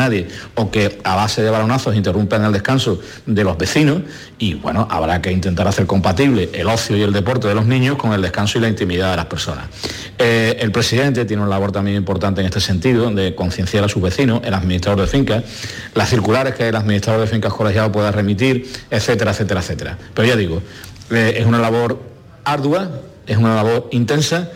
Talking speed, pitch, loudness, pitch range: 200 wpm, 110 Hz, -17 LUFS, 100-120 Hz